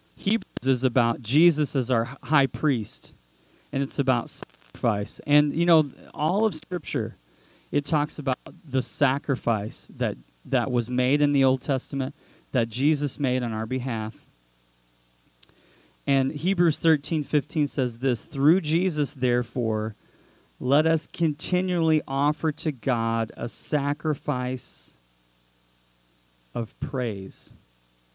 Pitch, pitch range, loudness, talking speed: 135 Hz, 115-150 Hz, -25 LUFS, 120 wpm